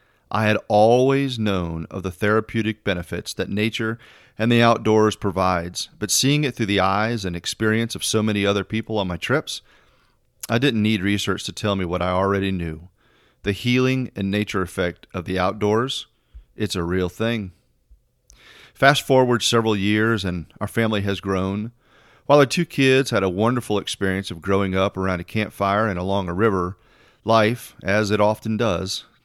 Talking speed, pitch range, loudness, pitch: 175 wpm, 95-115 Hz, -21 LUFS, 105 Hz